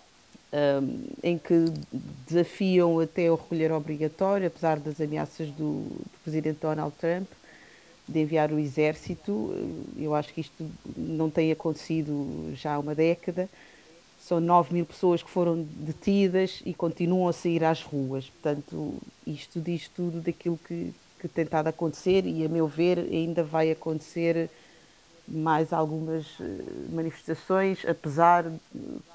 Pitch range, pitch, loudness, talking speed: 155-175 Hz, 165 Hz, -28 LUFS, 140 wpm